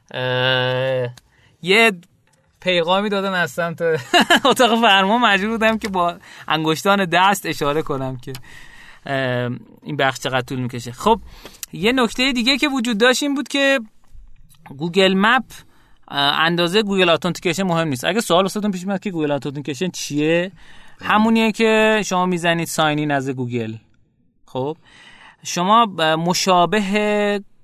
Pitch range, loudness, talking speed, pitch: 145-215 Hz, -18 LUFS, 125 wpm, 175 Hz